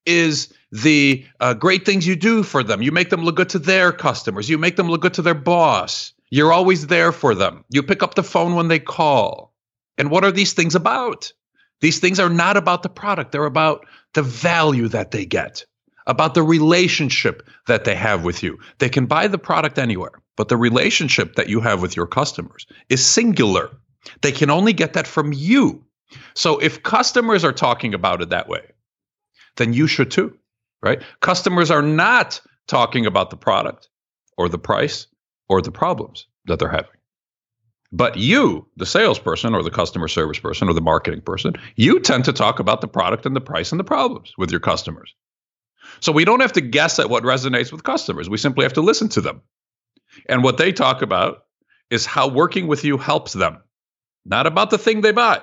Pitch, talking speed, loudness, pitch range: 160 Hz, 200 wpm, -17 LUFS, 130-185 Hz